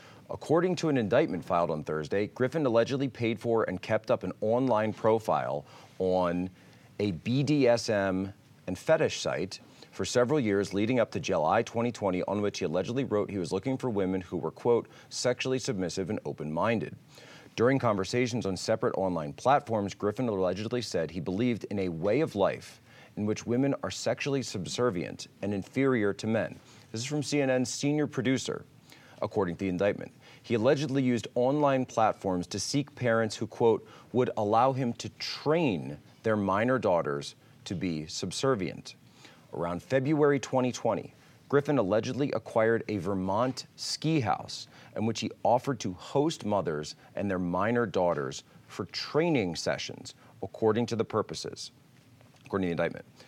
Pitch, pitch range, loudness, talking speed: 115 Hz, 95-130 Hz, -30 LUFS, 155 wpm